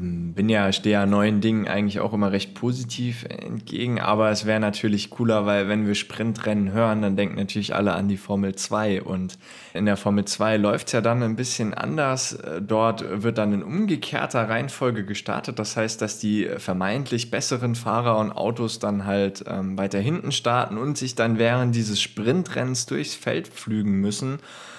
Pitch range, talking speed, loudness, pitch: 100-120 Hz, 175 wpm, -24 LUFS, 110 Hz